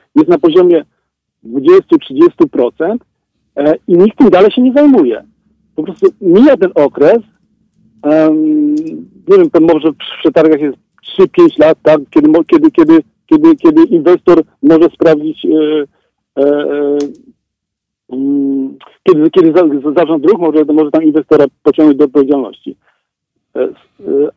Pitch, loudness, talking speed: 180 Hz, -9 LUFS, 105 wpm